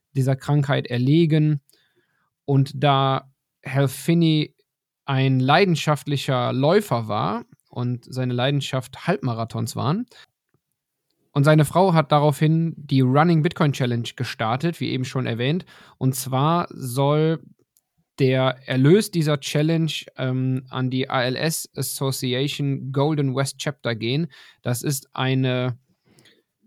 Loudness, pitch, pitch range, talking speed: -22 LUFS, 140 Hz, 130-155 Hz, 110 wpm